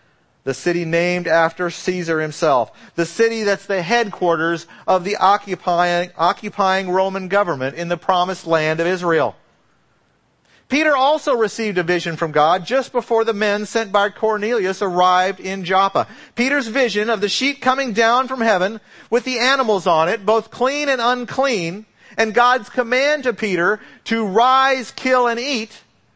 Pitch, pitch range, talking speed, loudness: 205 Hz, 180-240 Hz, 155 wpm, -18 LUFS